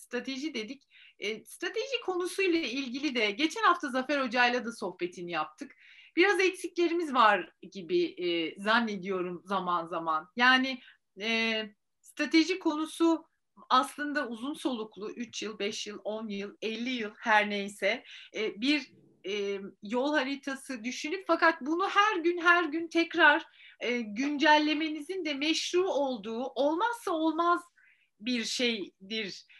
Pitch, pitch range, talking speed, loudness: 265 Hz, 215-330 Hz, 125 wpm, -29 LUFS